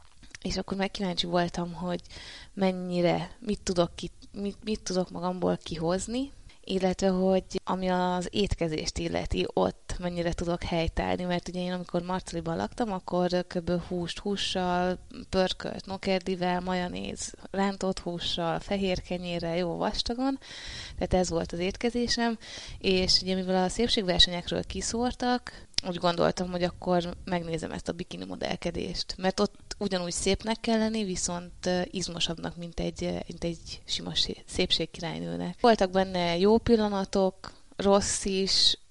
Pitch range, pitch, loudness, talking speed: 175-195 Hz, 180 Hz, -29 LUFS, 125 wpm